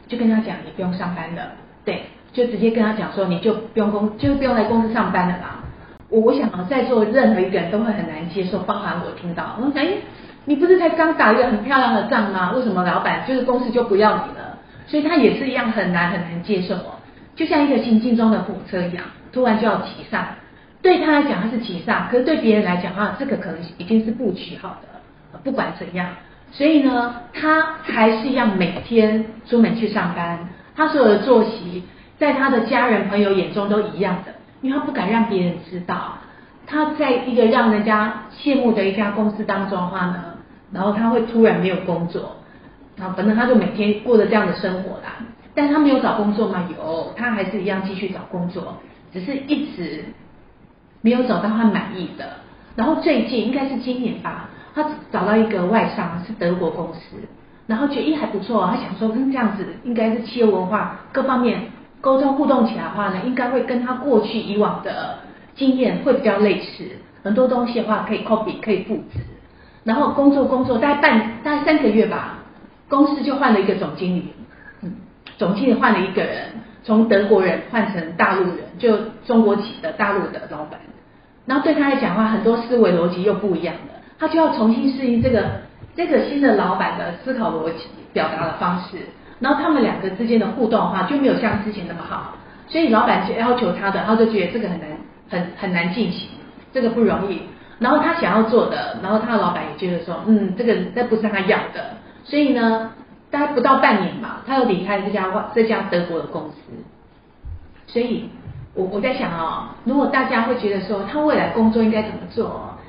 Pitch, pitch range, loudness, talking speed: 220 Hz, 195-250 Hz, -19 LUFS, 305 characters per minute